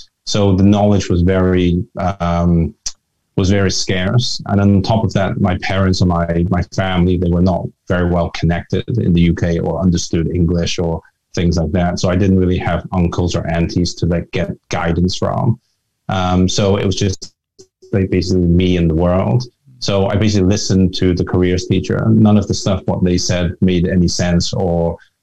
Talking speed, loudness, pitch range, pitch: 195 wpm, -15 LUFS, 85-100 Hz, 90 Hz